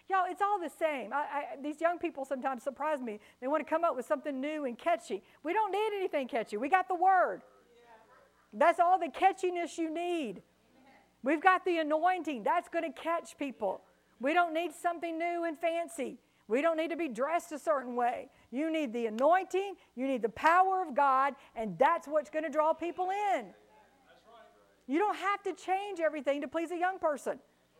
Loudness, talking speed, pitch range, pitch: -32 LUFS, 200 wpm, 280-350 Hz, 320 Hz